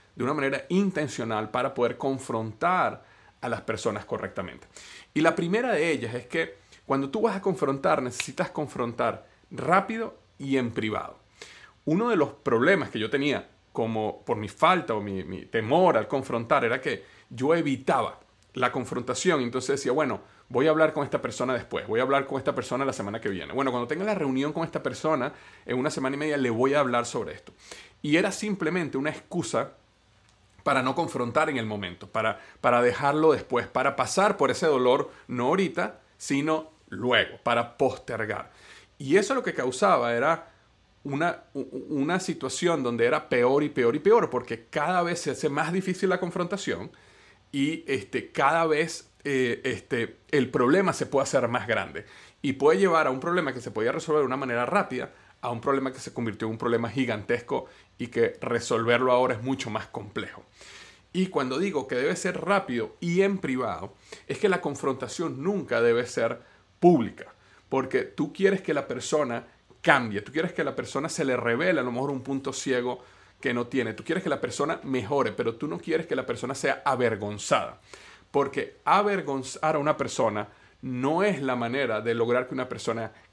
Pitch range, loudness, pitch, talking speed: 120-160 Hz, -27 LUFS, 135 Hz, 185 wpm